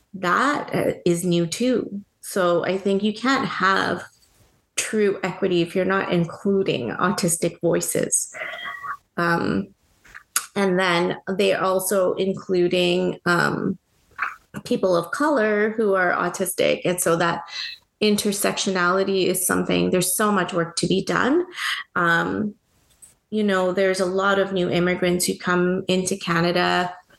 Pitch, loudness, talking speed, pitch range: 185 Hz, -22 LUFS, 130 wpm, 175-200 Hz